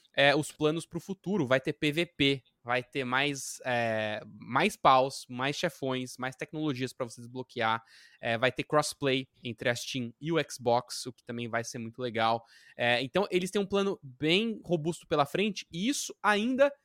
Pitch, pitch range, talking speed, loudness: 140 Hz, 125-170 Hz, 185 wpm, -30 LUFS